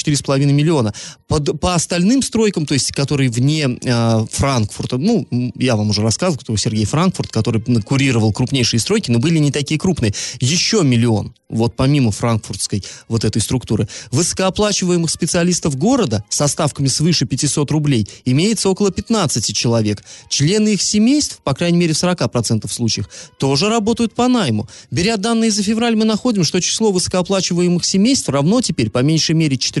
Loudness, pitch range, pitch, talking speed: -16 LUFS, 120-185 Hz, 145 Hz, 155 wpm